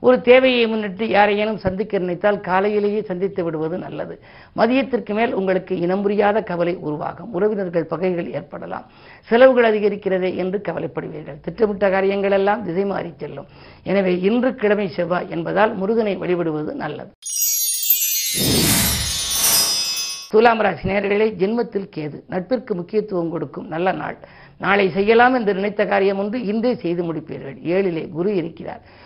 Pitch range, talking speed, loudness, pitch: 175-215 Hz, 120 wpm, -19 LUFS, 195 Hz